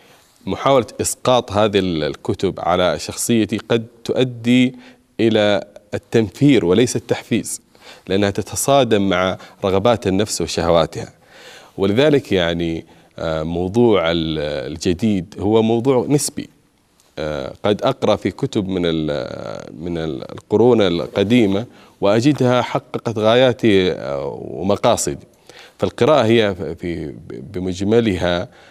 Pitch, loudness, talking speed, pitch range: 105 Hz, -18 LUFS, 85 wpm, 90-120 Hz